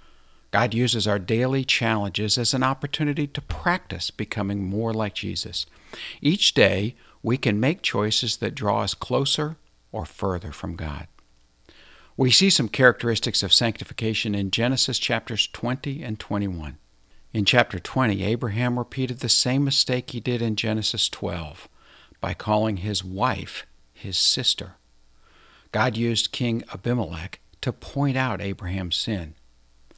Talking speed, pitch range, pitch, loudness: 135 wpm, 95-125 Hz, 110 Hz, -23 LUFS